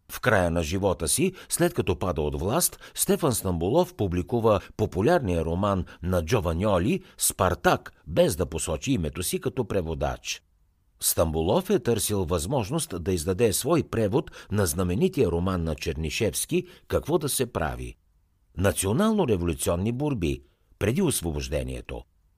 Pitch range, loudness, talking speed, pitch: 85-125 Hz, -26 LUFS, 120 wpm, 95 Hz